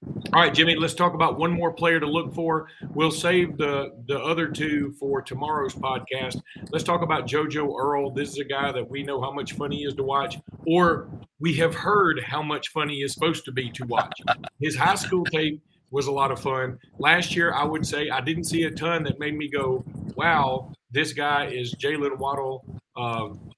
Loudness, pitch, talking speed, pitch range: -25 LUFS, 150 Hz, 215 wpm, 135-165 Hz